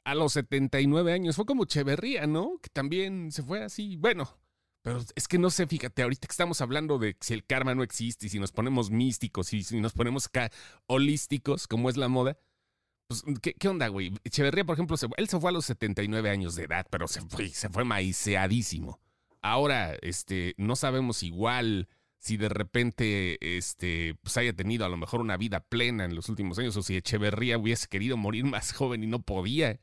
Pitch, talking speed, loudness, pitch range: 120 Hz, 205 wpm, -30 LUFS, 100-140 Hz